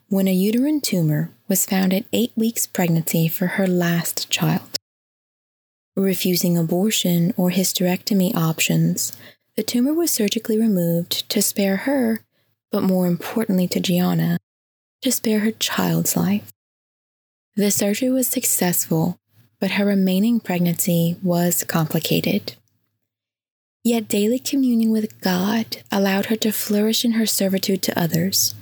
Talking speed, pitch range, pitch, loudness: 130 wpm, 170-220 Hz, 190 Hz, -20 LUFS